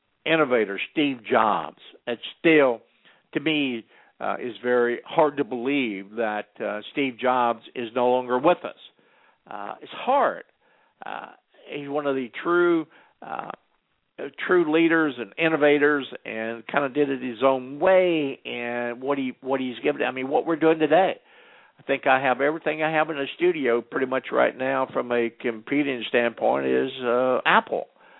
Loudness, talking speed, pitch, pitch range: -24 LUFS, 165 wpm, 135 Hz, 120-150 Hz